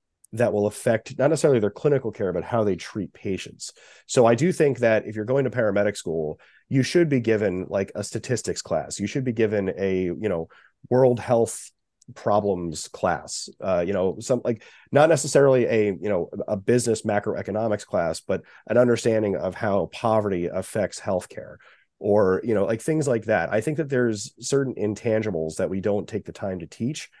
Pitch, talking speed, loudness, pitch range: 110 Hz, 190 wpm, -24 LUFS, 100-125 Hz